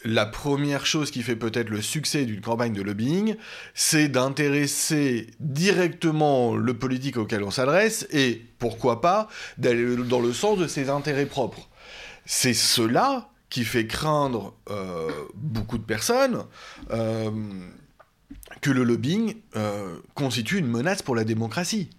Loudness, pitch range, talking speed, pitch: -24 LUFS, 115-155 Hz, 140 wpm, 130 Hz